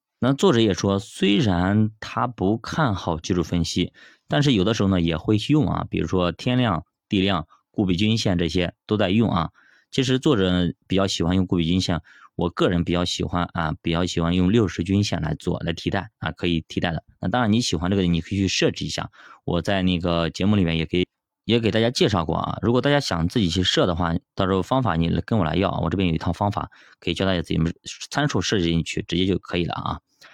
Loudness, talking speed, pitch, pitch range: -22 LUFS, 335 characters per minute, 95 Hz, 85-105 Hz